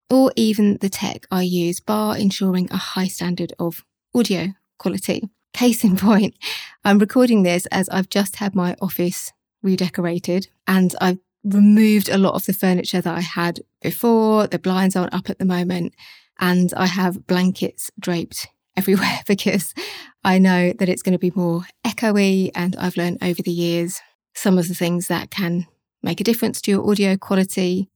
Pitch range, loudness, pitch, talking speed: 180-205 Hz, -19 LUFS, 190 Hz, 175 wpm